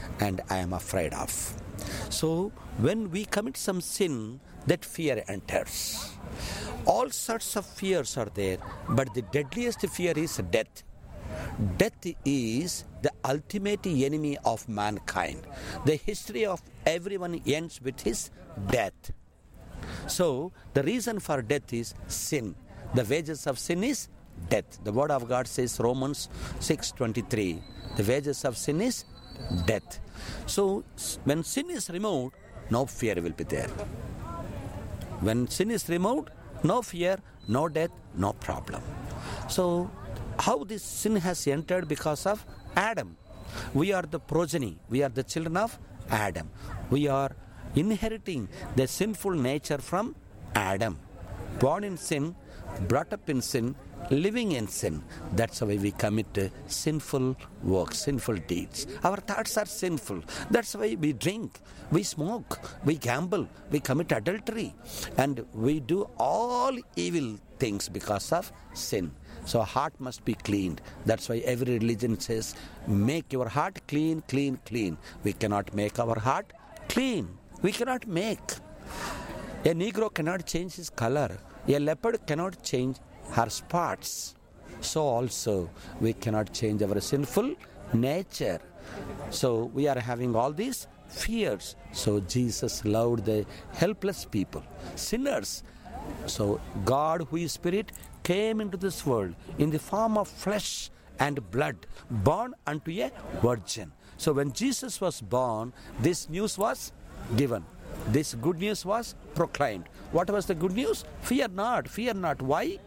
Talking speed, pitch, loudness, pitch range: 135 wpm, 135 Hz, -30 LUFS, 105-175 Hz